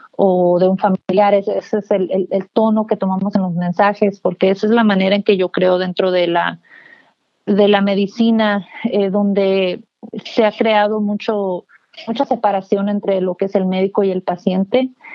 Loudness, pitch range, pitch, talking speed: -16 LUFS, 190-215 Hz, 200 Hz, 185 wpm